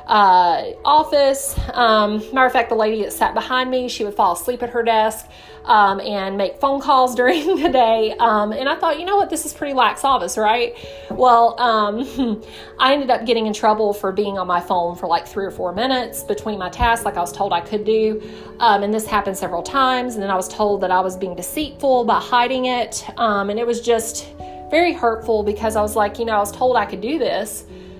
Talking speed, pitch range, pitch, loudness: 230 wpm, 205-255 Hz, 225 Hz, -18 LUFS